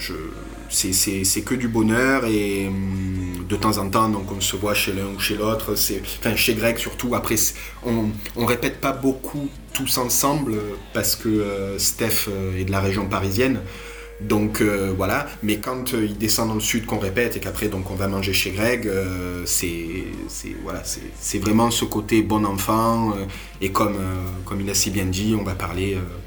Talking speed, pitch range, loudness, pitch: 210 wpm, 95-115 Hz, -22 LUFS, 105 Hz